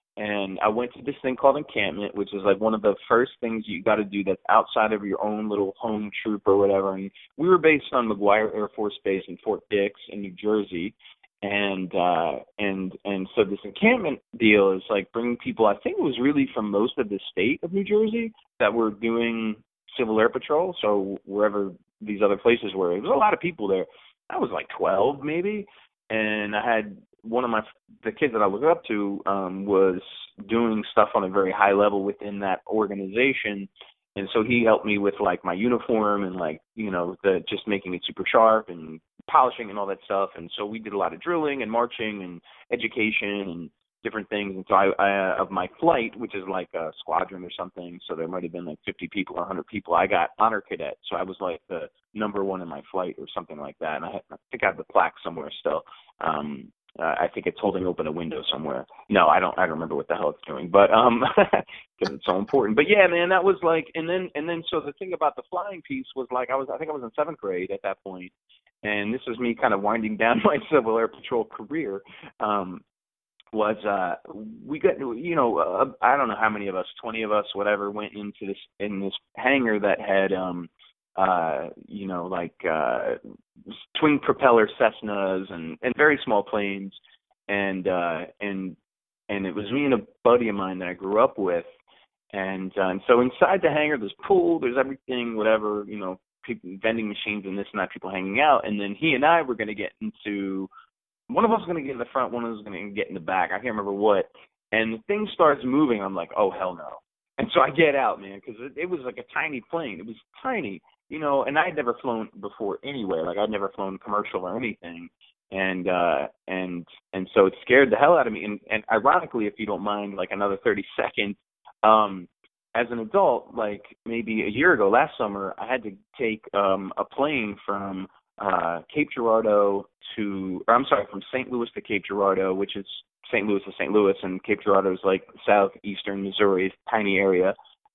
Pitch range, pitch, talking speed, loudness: 95-115 Hz, 105 Hz, 220 wpm, -24 LUFS